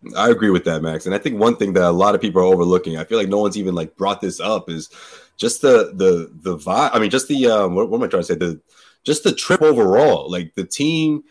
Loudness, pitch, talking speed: -17 LUFS, 100 Hz, 270 wpm